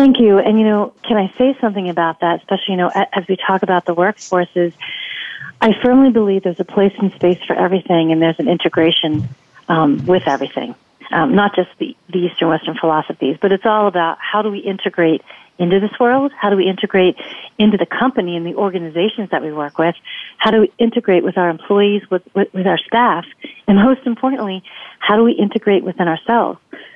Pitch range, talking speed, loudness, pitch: 175-215 Hz, 200 wpm, -15 LUFS, 195 Hz